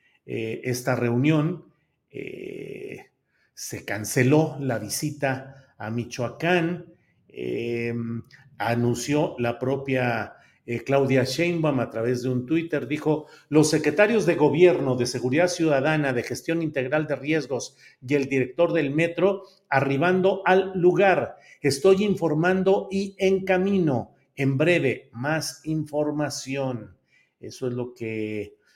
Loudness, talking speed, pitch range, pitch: -24 LUFS, 115 wpm, 125-170 Hz, 145 Hz